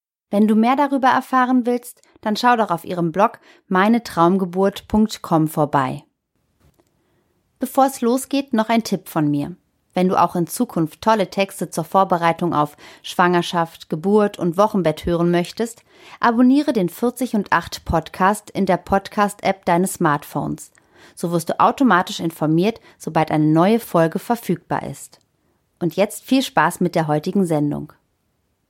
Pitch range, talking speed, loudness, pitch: 170-225 Hz, 145 wpm, -19 LUFS, 190 Hz